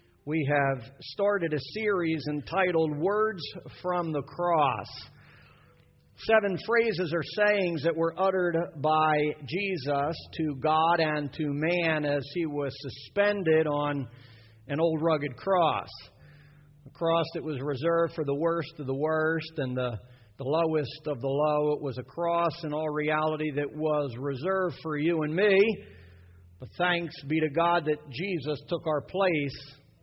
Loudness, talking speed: -28 LUFS, 150 wpm